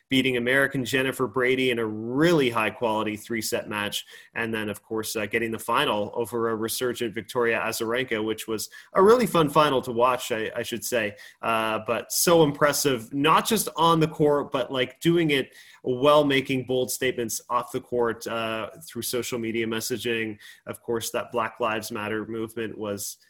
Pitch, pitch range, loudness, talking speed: 120 Hz, 110-130 Hz, -25 LUFS, 180 wpm